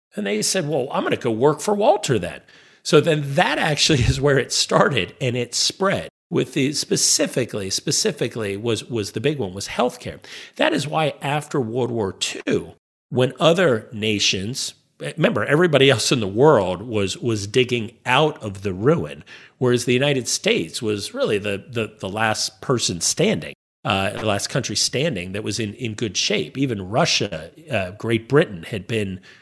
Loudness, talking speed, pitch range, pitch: -20 LUFS, 175 wpm, 105-145 Hz, 120 Hz